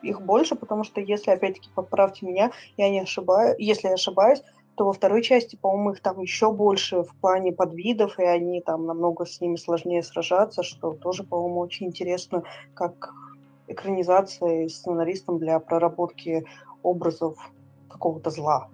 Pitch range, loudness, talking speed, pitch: 170-195 Hz, -24 LUFS, 150 wpm, 180 Hz